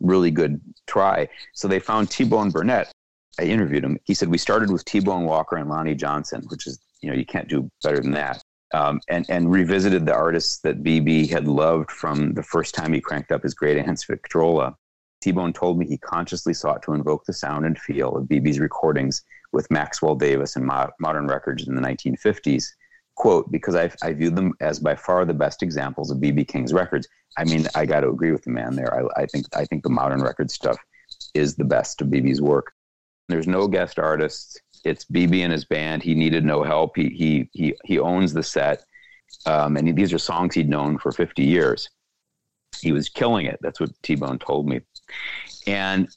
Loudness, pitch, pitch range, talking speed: -22 LUFS, 80 Hz, 75-85 Hz, 205 wpm